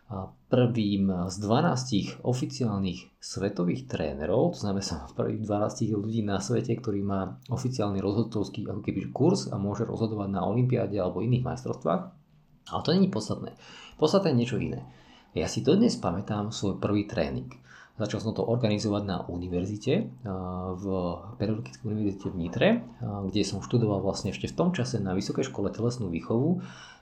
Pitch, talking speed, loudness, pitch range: 105 Hz, 155 wpm, -29 LUFS, 95-115 Hz